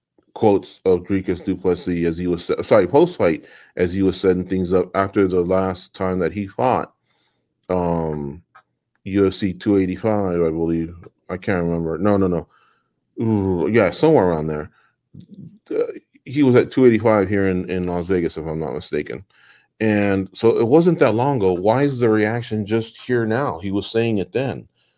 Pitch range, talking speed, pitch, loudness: 90-110 Hz, 175 wpm, 95 Hz, -19 LUFS